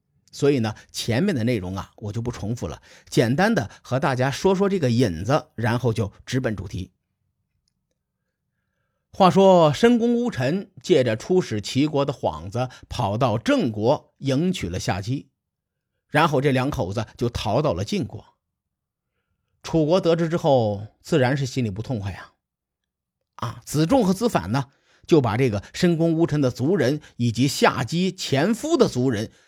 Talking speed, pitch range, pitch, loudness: 230 characters per minute, 110-165 Hz, 130 Hz, -22 LUFS